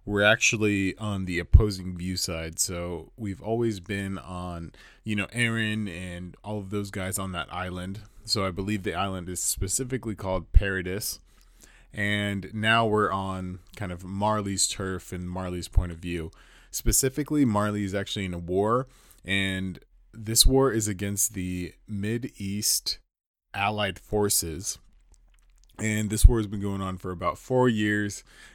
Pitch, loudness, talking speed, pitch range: 100 Hz, -27 LUFS, 155 wpm, 90-105 Hz